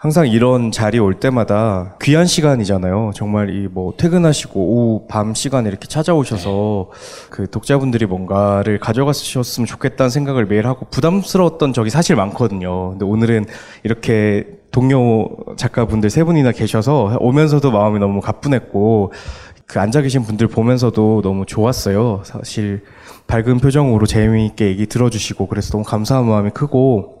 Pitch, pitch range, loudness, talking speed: 110 Hz, 105-130 Hz, -16 LUFS, 360 characters per minute